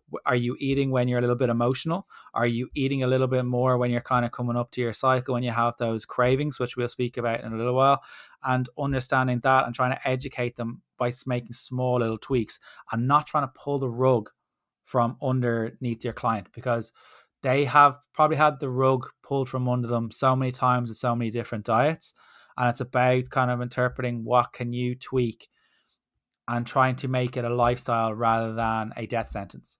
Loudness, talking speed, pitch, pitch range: -25 LUFS, 205 wpm, 125 Hz, 120-130 Hz